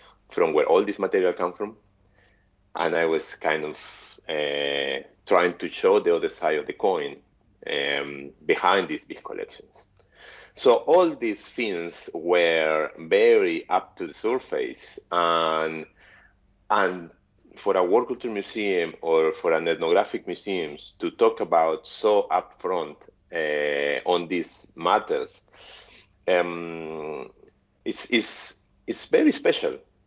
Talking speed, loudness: 130 wpm, -24 LUFS